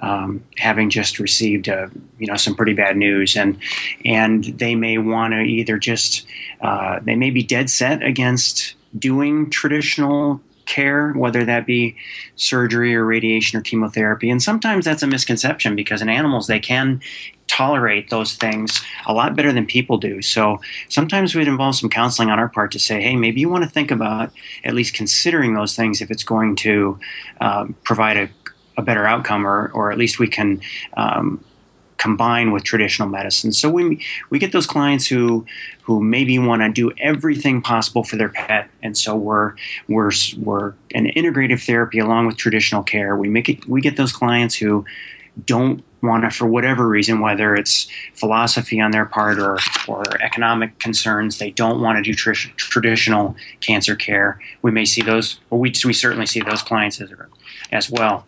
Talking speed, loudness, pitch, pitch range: 180 wpm, -17 LUFS, 115 Hz, 105-120 Hz